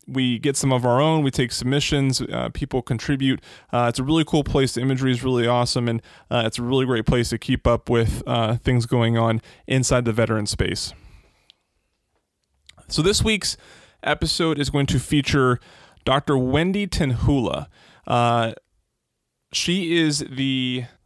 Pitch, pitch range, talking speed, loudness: 130 Hz, 120-140 Hz, 160 wpm, -21 LUFS